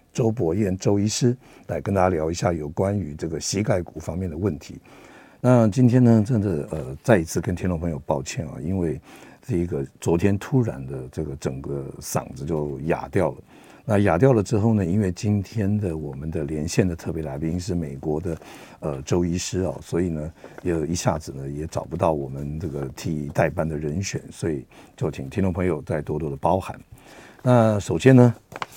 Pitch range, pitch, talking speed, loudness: 75-105 Hz, 85 Hz, 280 characters per minute, -24 LUFS